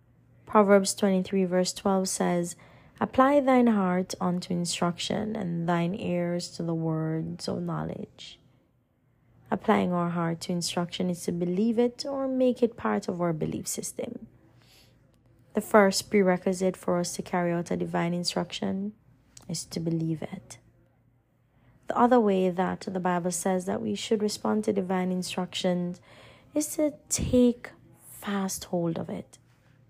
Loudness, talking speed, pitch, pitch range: -27 LUFS, 145 wpm, 185 Hz, 175-205 Hz